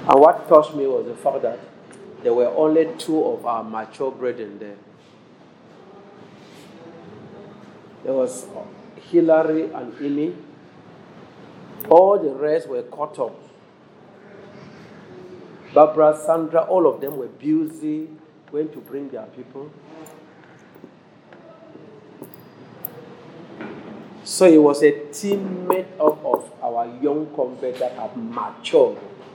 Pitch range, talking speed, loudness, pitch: 145-200 Hz, 110 wpm, -20 LUFS, 160 Hz